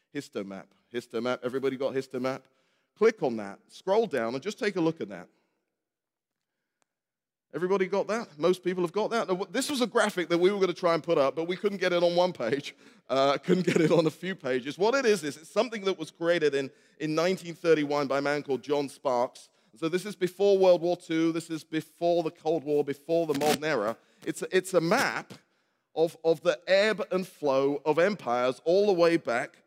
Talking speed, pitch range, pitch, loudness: 215 wpm, 145-185 Hz, 165 Hz, -28 LUFS